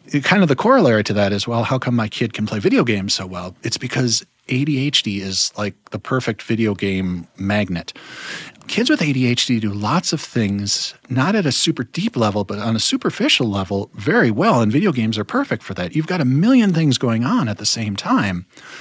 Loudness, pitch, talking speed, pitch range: -18 LUFS, 115 Hz, 210 wpm, 100-130 Hz